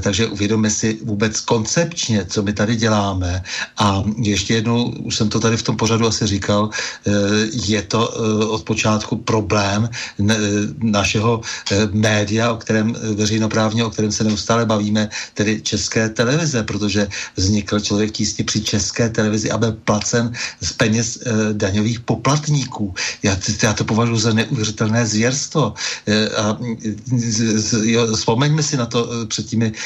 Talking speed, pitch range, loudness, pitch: 135 wpm, 105-115 Hz, -18 LUFS, 110 Hz